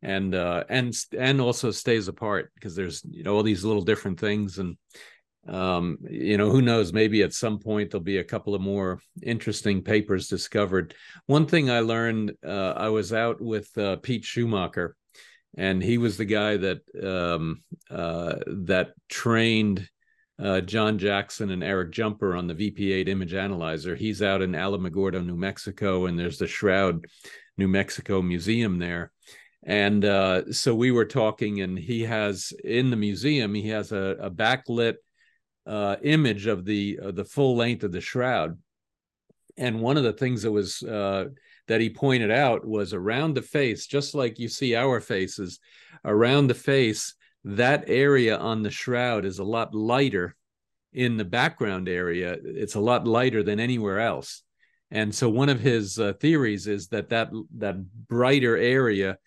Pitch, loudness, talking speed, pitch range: 105 Hz, -25 LUFS, 170 wpm, 95-120 Hz